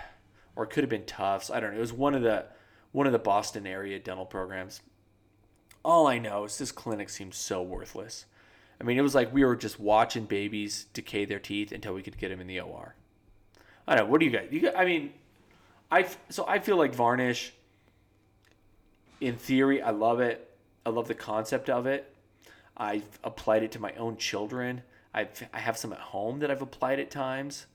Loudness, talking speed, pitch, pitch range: -29 LUFS, 210 wpm, 110 Hz, 105-125 Hz